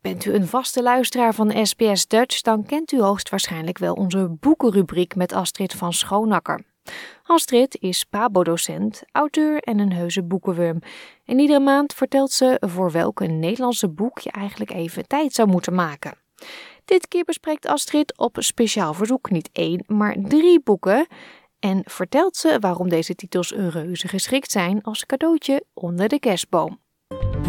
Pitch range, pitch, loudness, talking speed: 180-265 Hz, 210 Hz, -20 LUFS, 155 wpm